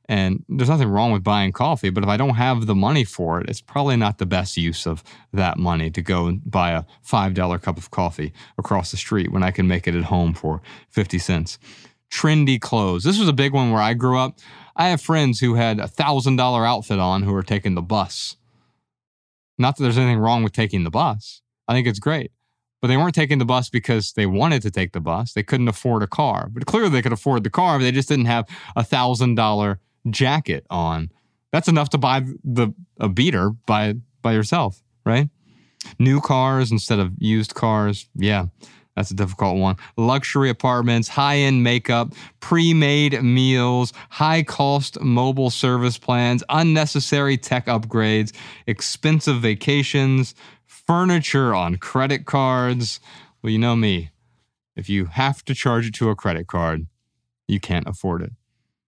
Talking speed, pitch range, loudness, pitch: 185 wpm, 100-135 Hz, -20 LUFS, 120 Hz